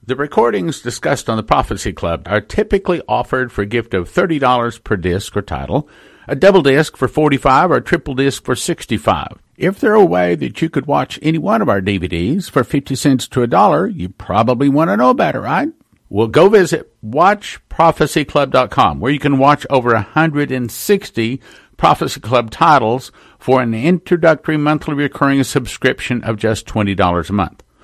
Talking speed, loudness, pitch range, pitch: 175 wpm, -15 LUFS, 110-150 Hz, 130 Hz